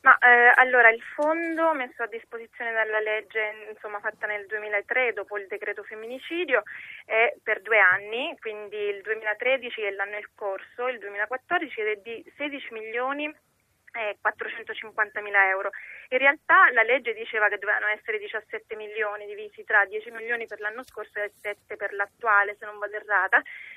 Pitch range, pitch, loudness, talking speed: 210-255 Hz, 220 Hz, -24 LUFS, 160 wpm